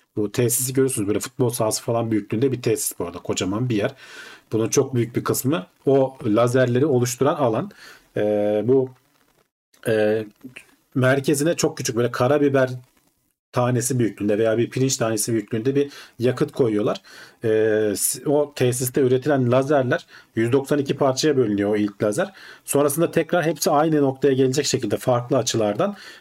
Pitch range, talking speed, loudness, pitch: 110-140 Hz, 140 wpm, -21 LUFS, 130 Hz